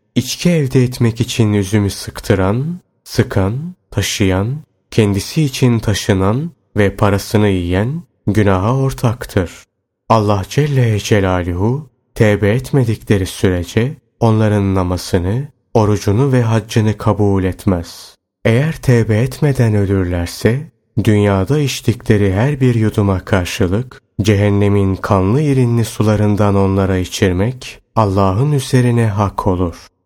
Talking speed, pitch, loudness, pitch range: 100 wpm, 105 Hz, -15 LUFS, 100-125 Hz